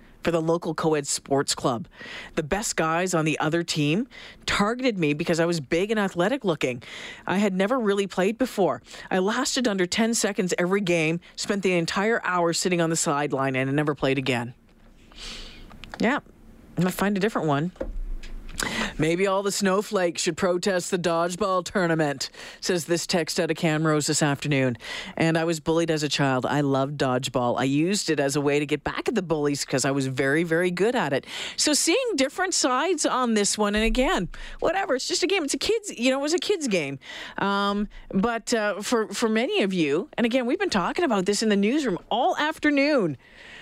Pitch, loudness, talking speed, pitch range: 180 Hz, -24 LUFS, 200 wpm, 155-225 Hz